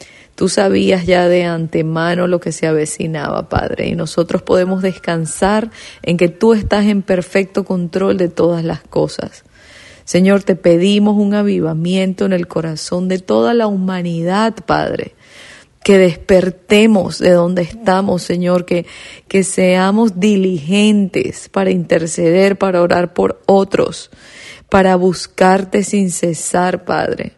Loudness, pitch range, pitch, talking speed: -14 LUFS, 175-195 Hz, 185 Hz, 130 wpm